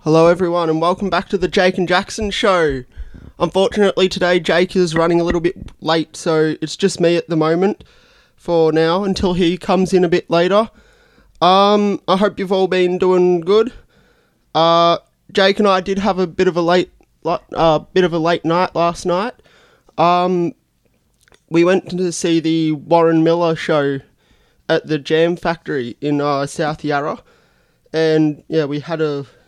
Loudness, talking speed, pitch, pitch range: -16 LUFS, 175 wpm, 175 Hz, 160-185 Hz